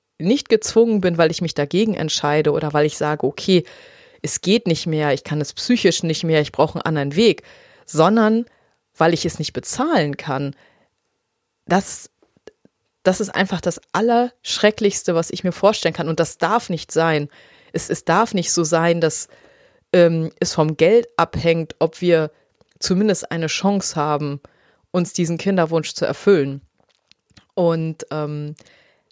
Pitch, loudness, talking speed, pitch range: 170 Hz, -19 LUFS, 155 wpm, 155-195 Hz